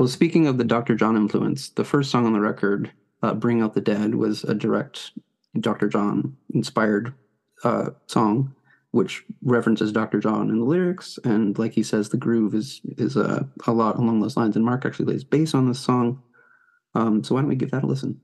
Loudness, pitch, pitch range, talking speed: -23 LUFS, 115 Hz, 110-135 Hz, 210 wpm